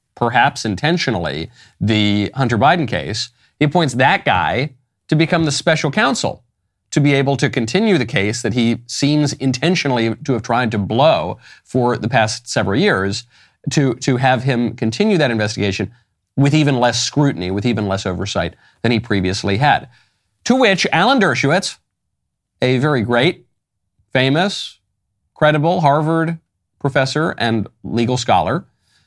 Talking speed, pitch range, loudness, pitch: 140 wpm, 105-145 Hz, -17 LUFS, 120 Hz